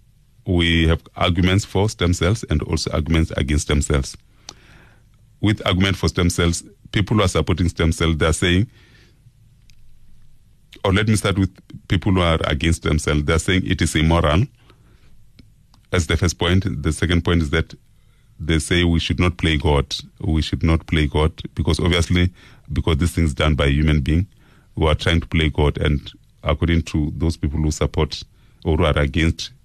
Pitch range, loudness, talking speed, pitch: 80-100 Hz, -20 LUFS, 175 wpm, 85 Hz